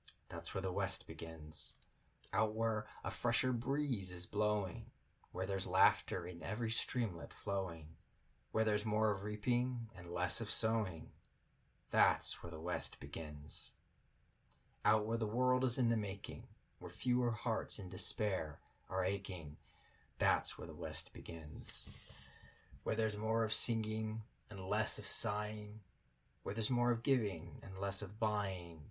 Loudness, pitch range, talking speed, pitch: -38 LUFS, 90-115 Hz, 145 wpm, 105 Hz